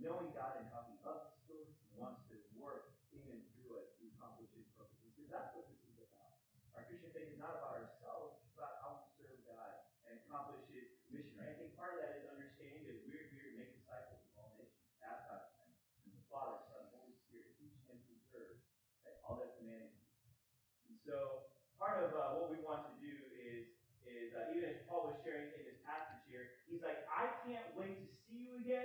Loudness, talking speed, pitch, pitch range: -51 LUFS, 210 wpm, 135 Hz, 120-165 Hz